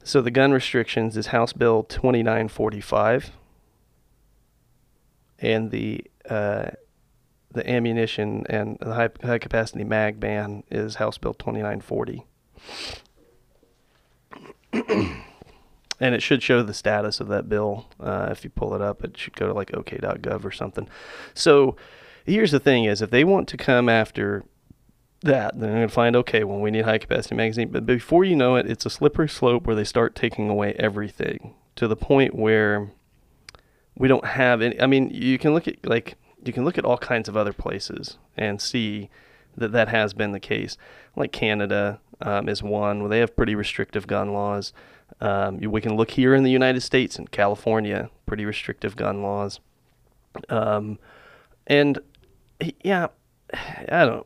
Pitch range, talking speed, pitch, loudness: 105-125 Hz, 165 wpm, 110 Hz, -23 LUFS